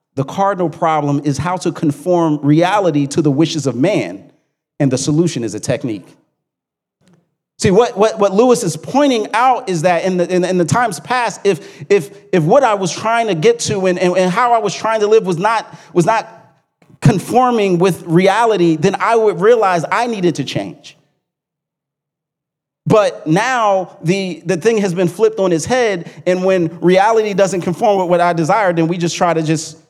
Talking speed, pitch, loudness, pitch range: 195 wpm, 180 Hz, -14 LUFS, 160-200 Hz